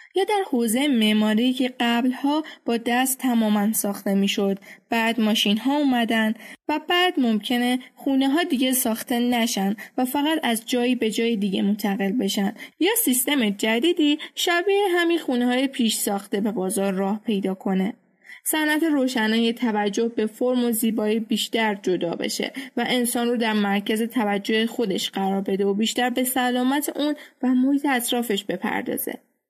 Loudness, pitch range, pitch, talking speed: -22 LUFS, 215-265 Hz, 235 Hz, 150 wpm